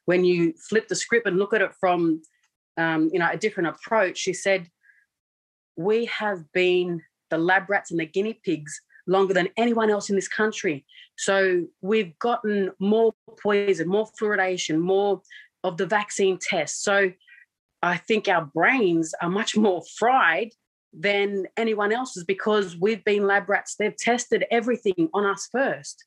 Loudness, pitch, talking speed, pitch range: -23 LUFS, 195 Hz, 160 wpm, 180-215 Hz